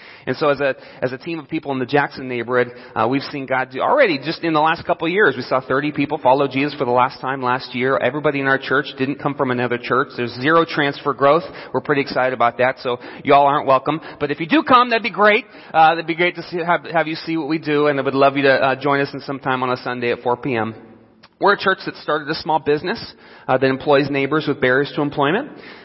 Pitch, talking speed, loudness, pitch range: 140 Hz, 265 wpm, -18 LUFS, 130-155 Hz